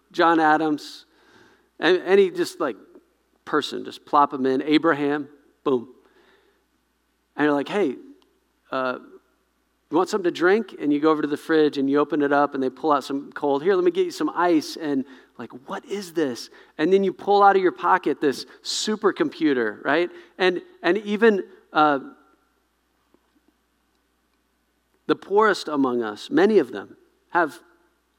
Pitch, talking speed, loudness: 185 Hz, 160 wpm, -22 LUFS